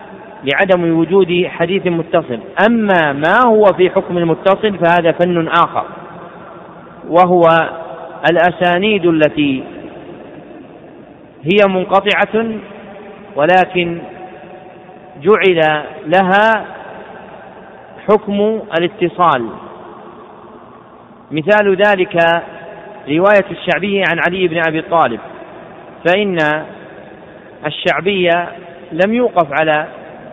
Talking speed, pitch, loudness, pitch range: 75 wpm, 180 Hz, -13 LUFS, 170-200 Hz